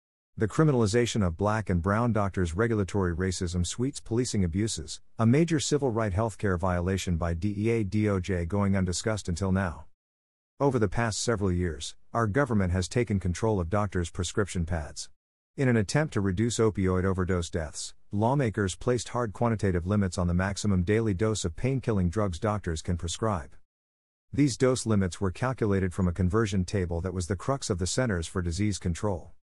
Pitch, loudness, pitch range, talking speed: 100 Hz, -28 LUFS, 90-110 Hz, 170 wpm